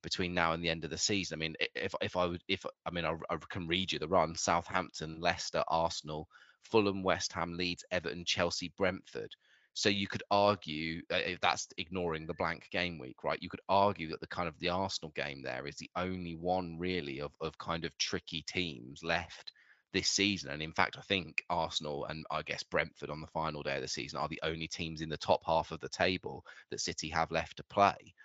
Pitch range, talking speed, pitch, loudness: 80-90 Hz, 225 wpm, 85 Hz, -35 LUFS